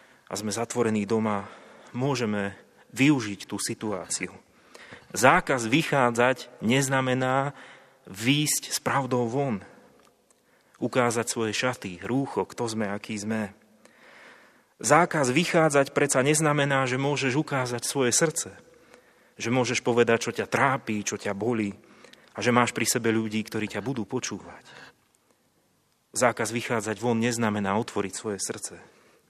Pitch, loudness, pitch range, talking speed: 120 Hz, -26 LUFS, 110-135 Hz, 120 wpm